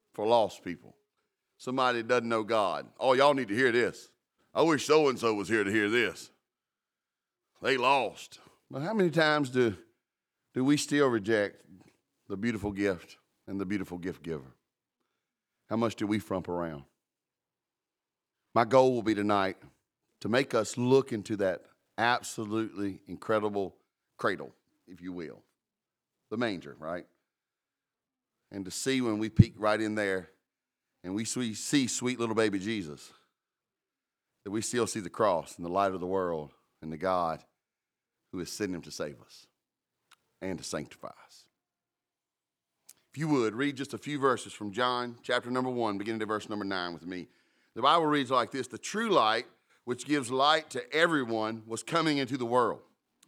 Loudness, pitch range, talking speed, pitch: -30 LUFS, 100-125 Hz, 170 wpm, 115 Hz